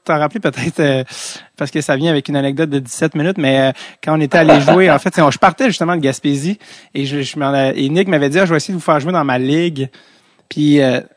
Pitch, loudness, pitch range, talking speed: 150 Hz, -14 LUFS, 140-170 Hz, 265 wpm